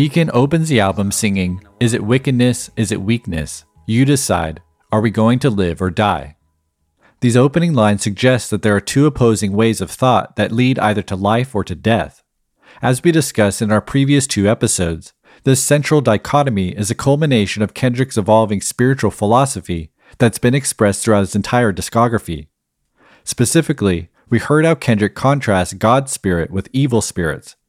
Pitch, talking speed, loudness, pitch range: 110 Hz, 165 wpm, -16 LUFS, 95-130 Hz